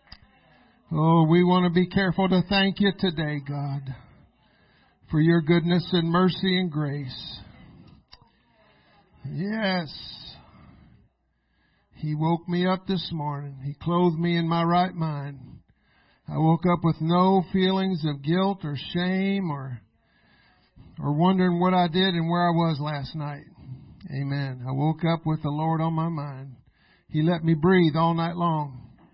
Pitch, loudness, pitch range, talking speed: 165 Hz, -24 LUFS, 145-180 Hz, 145 wpm